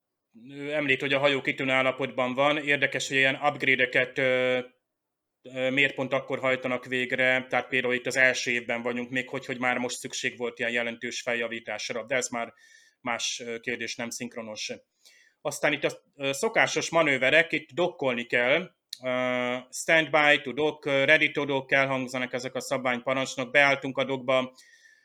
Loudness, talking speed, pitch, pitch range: -26 LUFS, 145 wpm, 130 Hz, 125-140 Hz